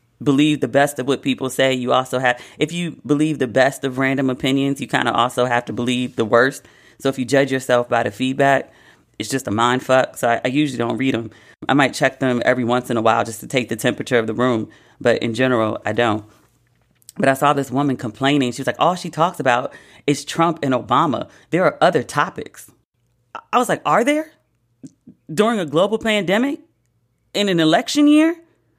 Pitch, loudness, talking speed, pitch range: 130 Hz, -18 LUFS, 215 wpm, 120-145 Hz